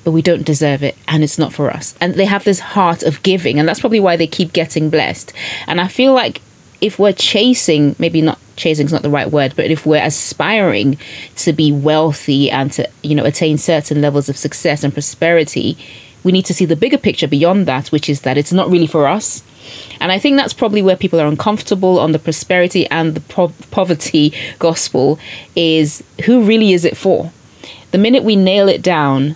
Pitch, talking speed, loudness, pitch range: 160 Hz, 215 wpm, -13 LUFS, 150-185 Hz